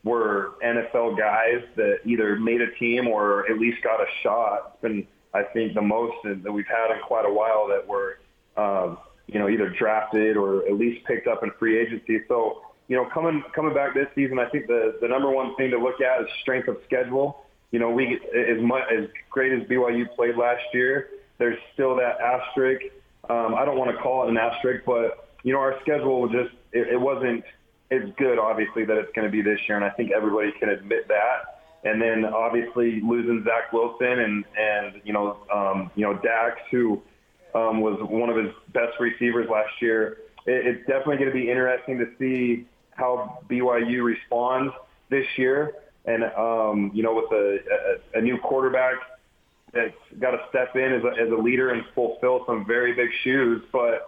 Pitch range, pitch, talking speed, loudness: 115-130 Hz, 120 Hz, 200 wpm, -24 LUFS